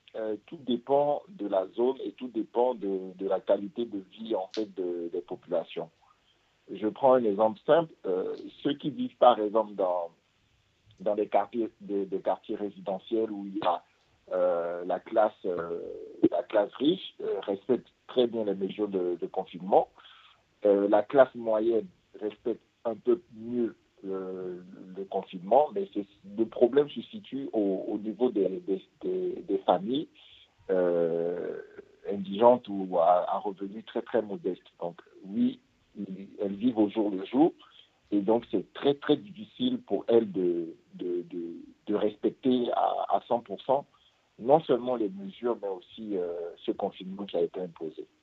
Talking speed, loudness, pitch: 160 wpm, -29 LUFS, 115 Hz